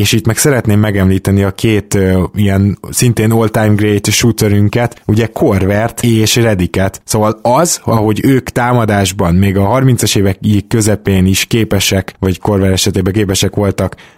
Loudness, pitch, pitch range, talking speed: -11 LUFS, 105 Hz, 100-115 Hz, 145 wpm